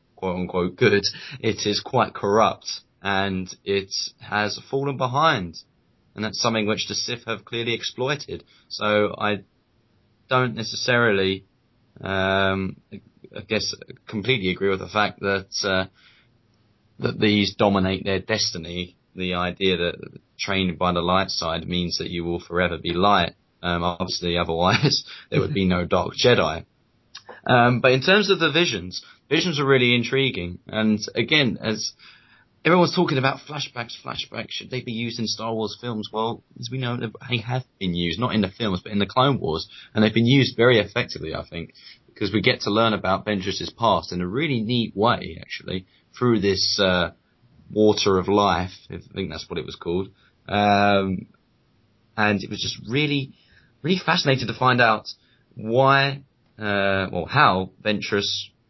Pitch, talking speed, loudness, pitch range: 105 Hz, 165 wpm, -22 LUFS, 95-120 Hz